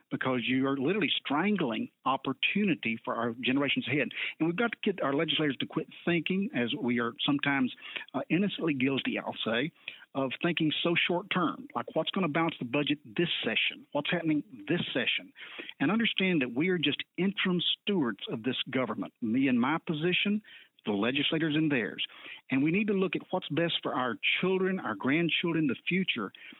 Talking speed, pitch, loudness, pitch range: 180 wpm, 165 Hz, -30 LUFS, 140-190 Hz